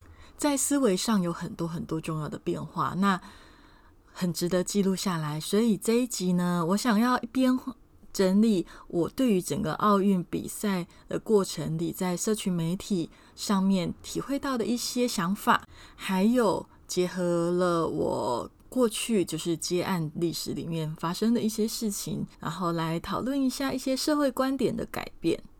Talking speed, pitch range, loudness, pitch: 240 characters per minute, 170-230 Hz, -28 LUFS, 195 Hz